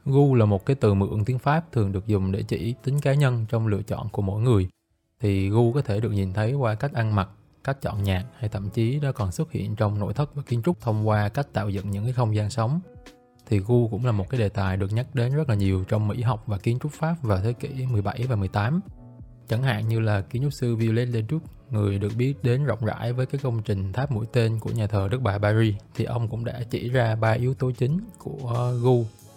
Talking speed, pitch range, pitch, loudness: 260 wpm, 105-130 Hz, 115 Hz, -25 LUFS